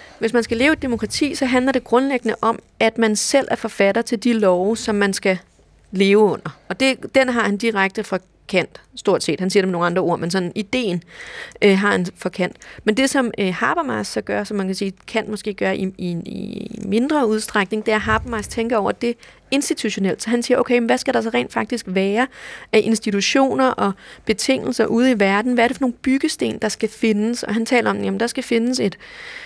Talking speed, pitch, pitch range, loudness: 230 wpm, 220 Hz, 200-245 Hz, -19 LUFS